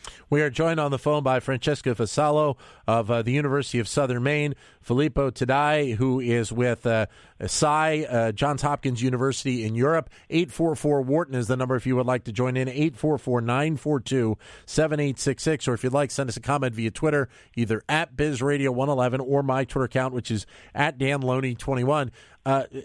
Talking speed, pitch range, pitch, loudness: 165 wpm, 125-145 Hz, 135 Hz, -25 LUFS